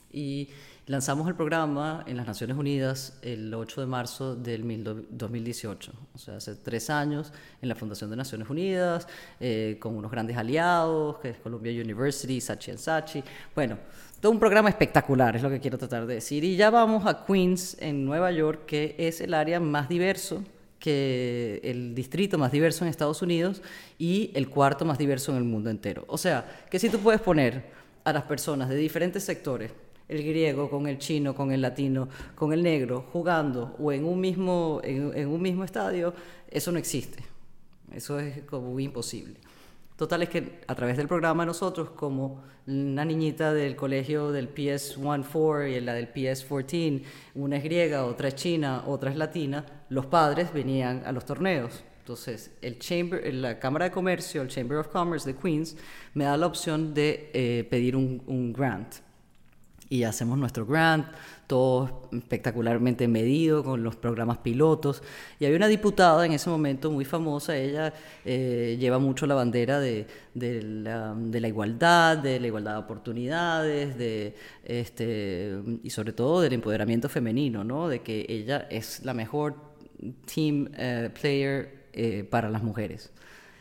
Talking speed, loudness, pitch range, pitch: 170 wpm, -28 LUFS, 120-160 Hz, 140 Hz